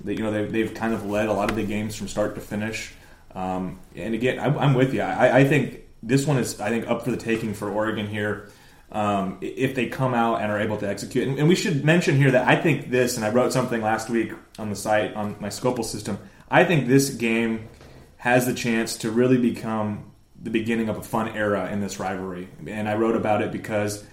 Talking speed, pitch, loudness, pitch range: 240 wpm, 110 Hz, -23 LUFS, 105-125 Hz